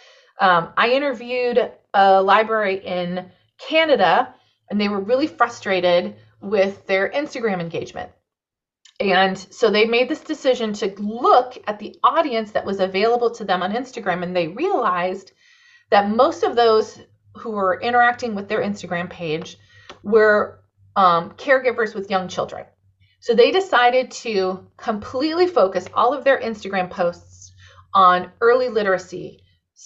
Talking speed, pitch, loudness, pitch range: 135 wpm, 205 Hz, -19 LUFS, 180-245 Hz